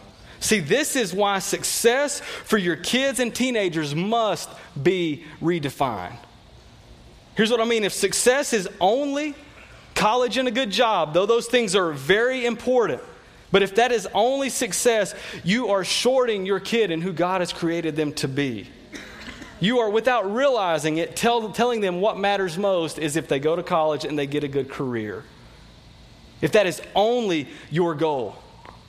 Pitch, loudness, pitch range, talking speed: 200 Hz, -22 LUFS, 165-235 Hz, 165 wpm